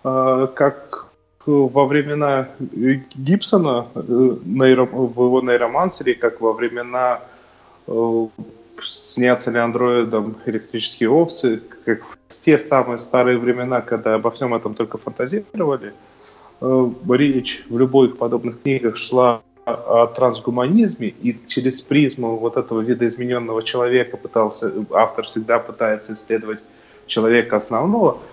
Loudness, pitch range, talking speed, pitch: -19 LUFS, 115-130 Hz, 105 wpm, 125 Hz